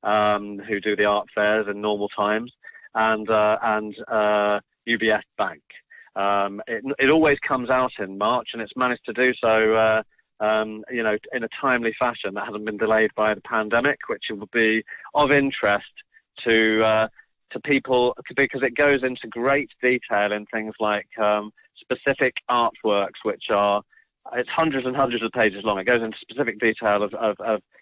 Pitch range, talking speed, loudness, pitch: 105-125 Hz, 175 wpm, -22 LUFS, 110 Hz